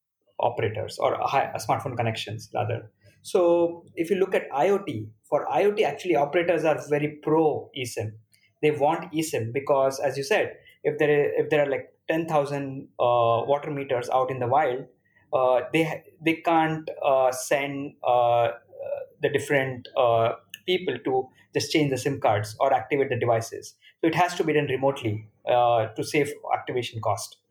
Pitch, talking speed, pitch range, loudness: 140 Hz, 170 wpm, 120-165 Hz, -25 LUFS